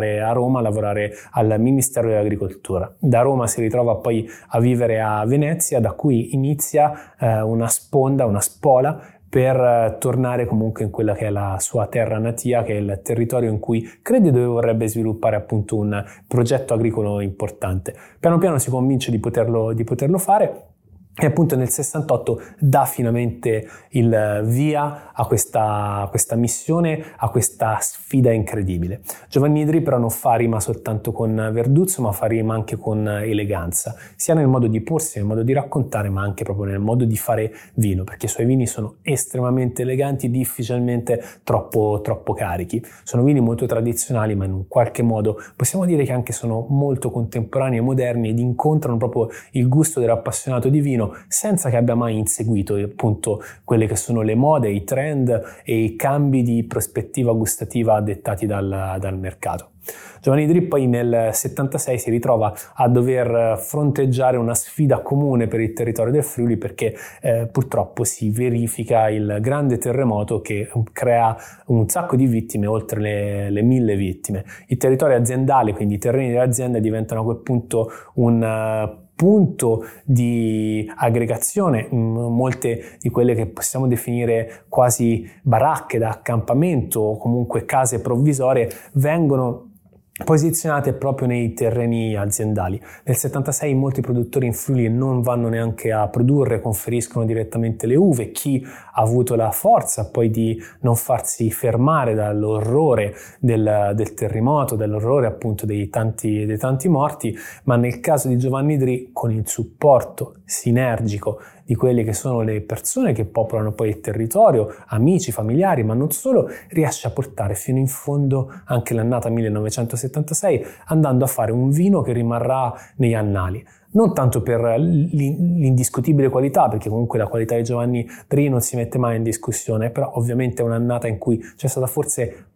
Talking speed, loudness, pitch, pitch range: 155 wpm, -20 LUFS, 120 Hz, 110-130 Hz